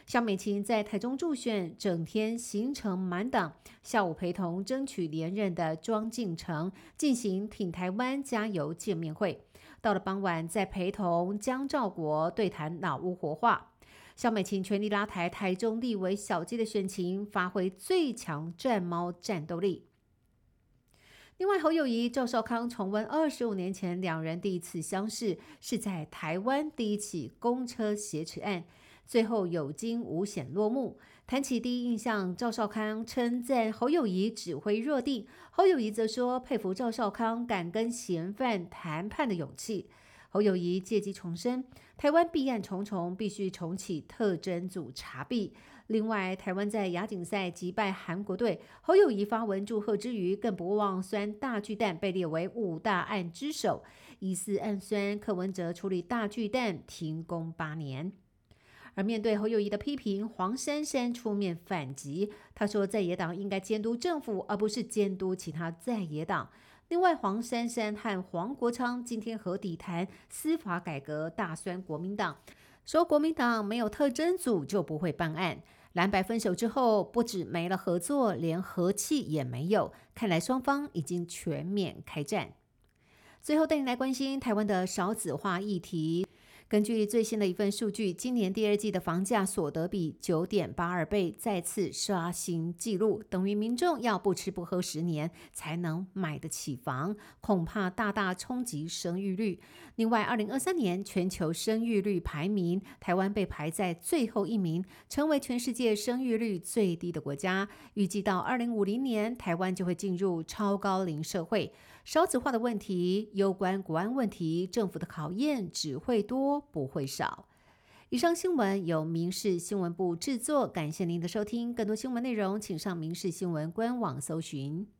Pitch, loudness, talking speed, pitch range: 200 Hz, -32 LUFS, 250 characters per minute, 175-230 Hz